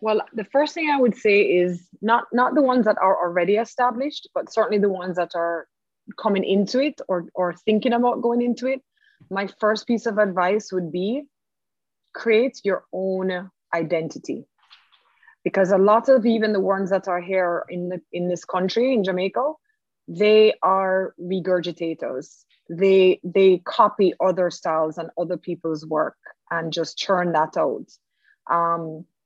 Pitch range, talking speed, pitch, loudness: 175-230 Hz, 160 wpm, 190 Hz, -22 LUFS